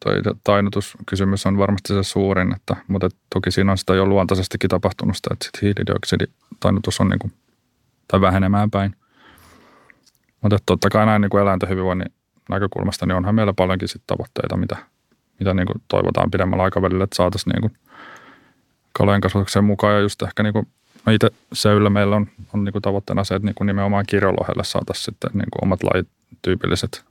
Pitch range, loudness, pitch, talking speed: 95-105 Hz, -20 LUFS, 100 Hz, 160 wpm